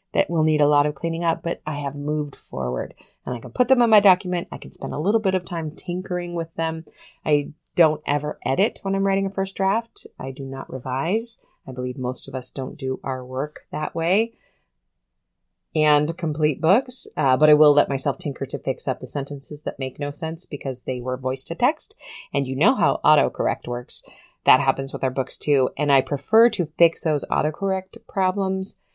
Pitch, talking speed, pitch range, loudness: 150 Hz, 210 wpm, 135-180 Hz, -23 LUFS